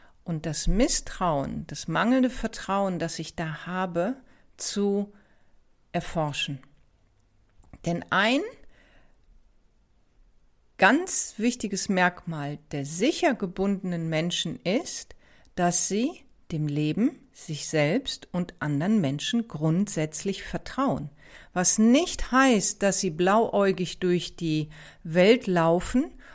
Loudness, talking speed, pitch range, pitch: -26 LUFS, 100 wpm, 160-225 Hz, 180 Hz